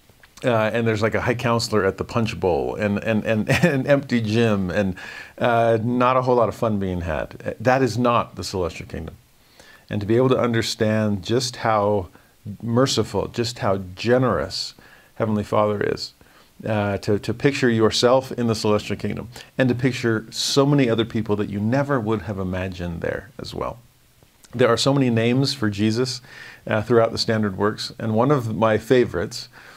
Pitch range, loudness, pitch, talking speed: 105-125 Hz, -21 LUFS, 115 Hz, 180 wpm